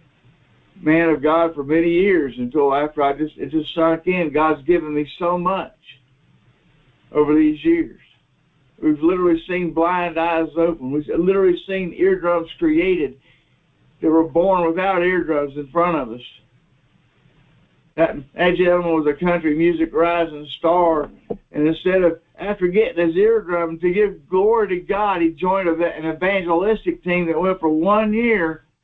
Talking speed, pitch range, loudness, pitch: 150 wpm, 155-185 Hz, -19 LUFS, 170 Hz